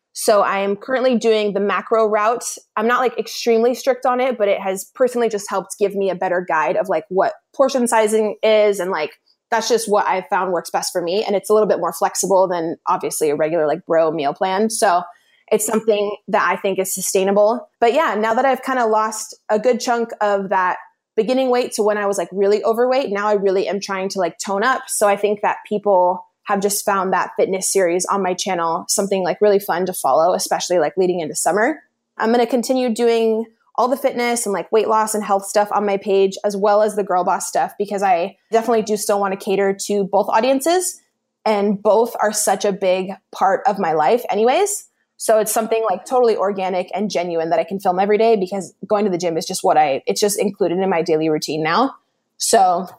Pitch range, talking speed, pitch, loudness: 190-225 Hz, 225 wpm, 205 Hz, -18 LUFS